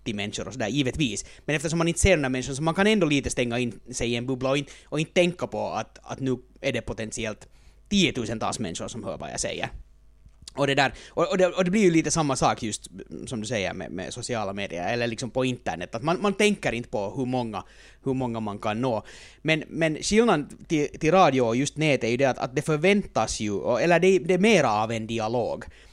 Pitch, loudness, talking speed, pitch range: 130 Hz, -25 LUFS, 240 wpm, 120-165 Hz